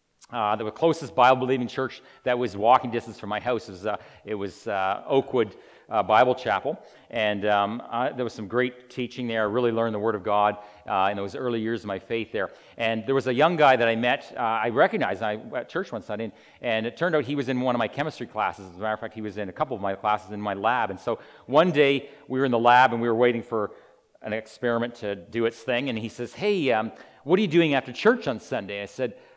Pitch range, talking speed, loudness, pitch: 105-125 Hz, 260 wpm, -25 LUFS, 115 Hz